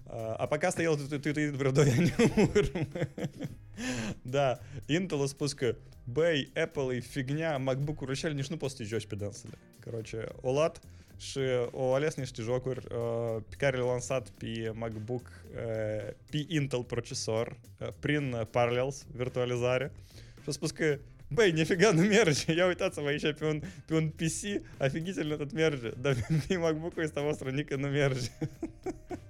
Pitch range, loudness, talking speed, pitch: 120-155 Hz, -31 LUFS, 120 wpm, 135 Hz